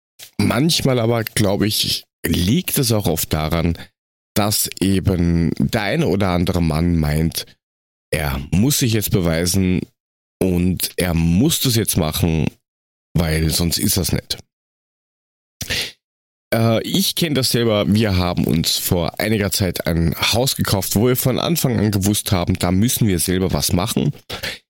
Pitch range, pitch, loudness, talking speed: 80-110 Hz, 95 Hz, -18 LUFS, 145 wpm